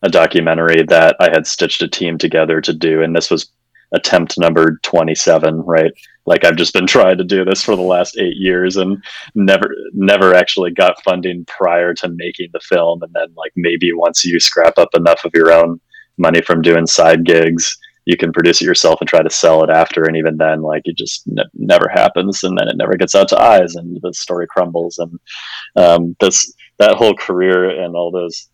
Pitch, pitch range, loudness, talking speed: 85 Hz, 80-90 Hz, -12 LUFS, 210 wpm